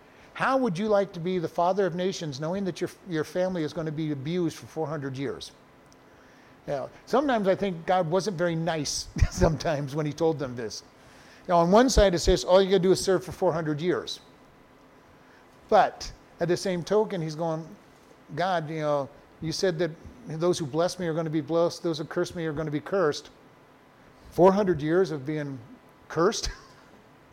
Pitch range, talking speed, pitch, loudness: 160-185 Hz, 195 wpm, 170 Hz, -27 LUFS